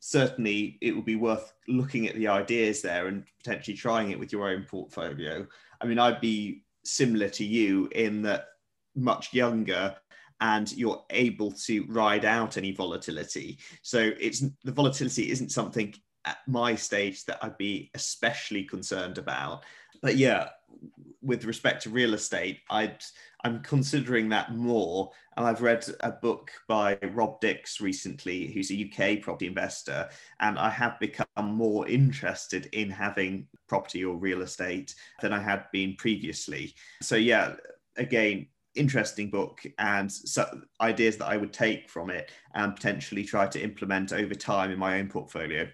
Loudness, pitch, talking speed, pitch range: -29 LUFS, 110 Hz, 155 wpm, 100-115 Hz